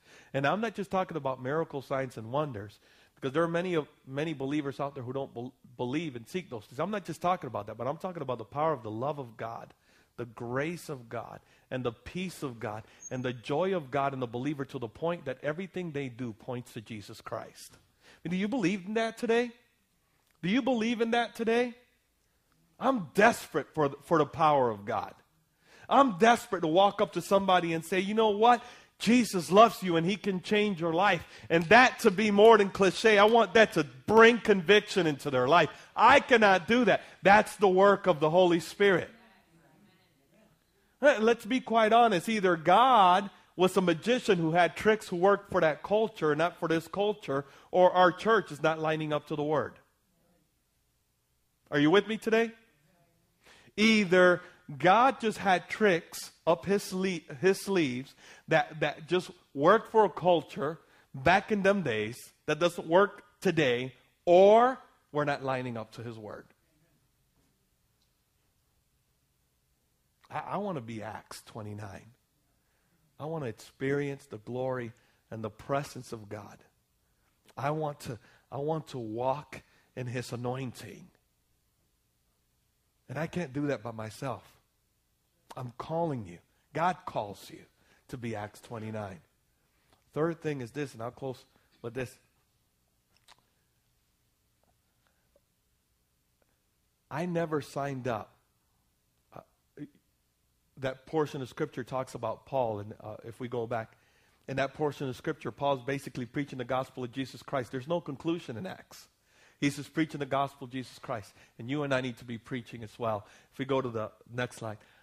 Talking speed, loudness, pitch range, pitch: 170 wpm, -28 LUFS, 125-185 Hz, 150 Hz